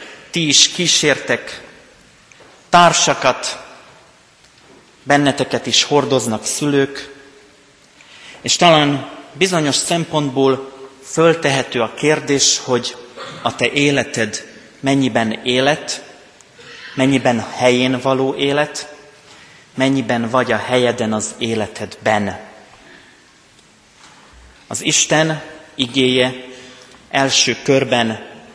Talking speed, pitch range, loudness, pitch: 75 wpm, 125-145 Hz, -16 LUFS, 135 Hz